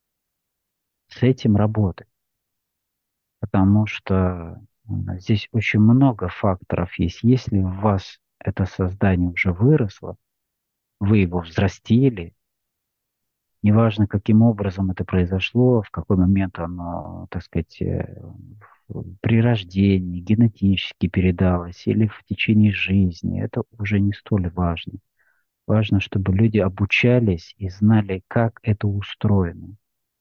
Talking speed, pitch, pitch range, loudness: 105 wpm, 100 Hz, 95-110 Hz, -20 LUFS